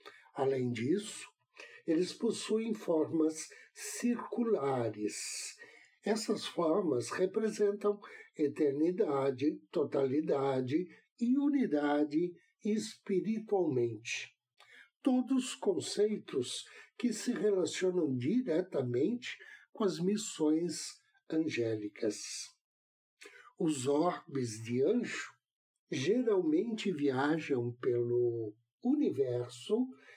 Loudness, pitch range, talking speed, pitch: -34 LUFS, 135-220 Hz, 65 wpm, 170 Hz